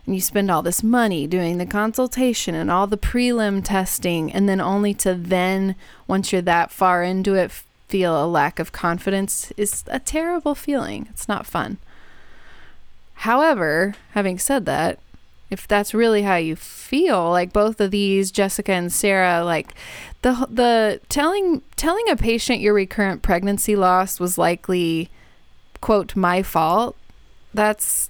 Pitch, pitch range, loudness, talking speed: 195 Hz, 180-220 Hz, -20 LUFS, 150 wpm